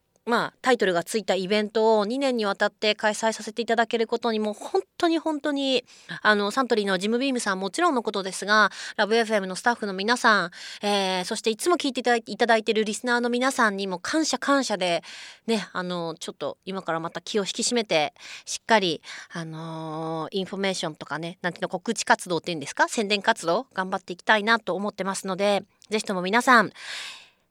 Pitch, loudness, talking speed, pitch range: 210 Hz, -25 LUFS, 430 characters per minute, 190-235 Hz